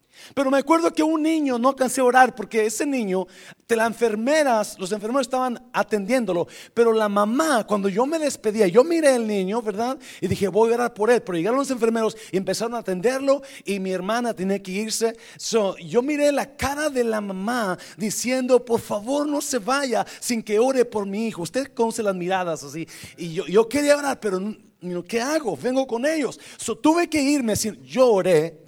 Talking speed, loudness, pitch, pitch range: 200 wpm, -22 LUFS, 230 Hz, 205-260 Hz